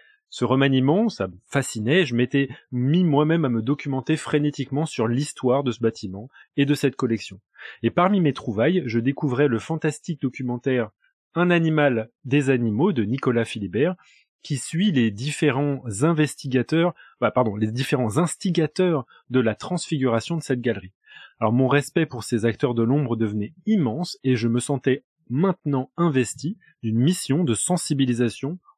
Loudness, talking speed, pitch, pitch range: -23 LUFS, 155 wpm, 135 Hz, 120-155 Hz